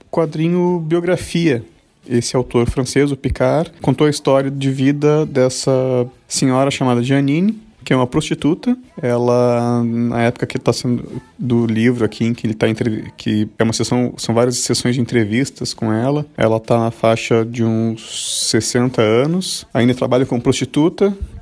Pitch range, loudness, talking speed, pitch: 120-140 Hz, -17 LUFS, 160 wpm, 125 Hz